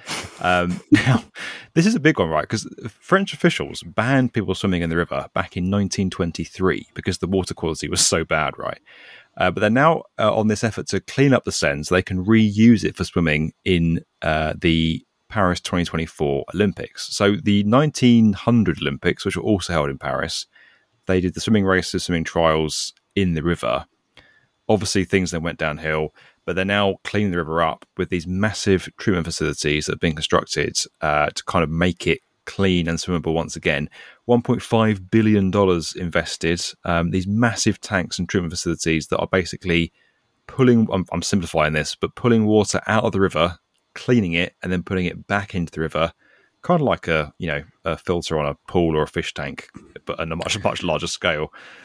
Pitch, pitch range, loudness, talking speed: 90 Hz, 80-105 Hz, -21 LUFS, 190 wpm